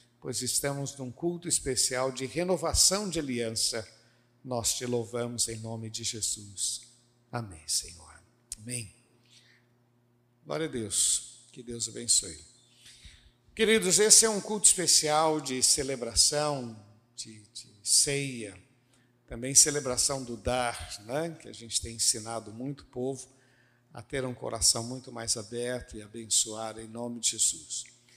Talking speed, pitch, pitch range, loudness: 130 wpm, 120 Hz, 115-130 Hz, -27 LUFS